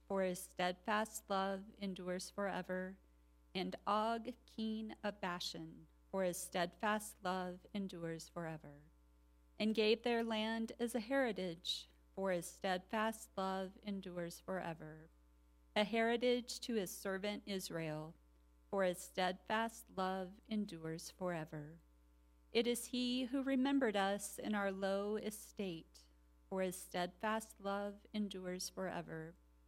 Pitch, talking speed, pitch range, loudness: 190 Hz, 115 wpm, 165-215 Hz, -41 LUFS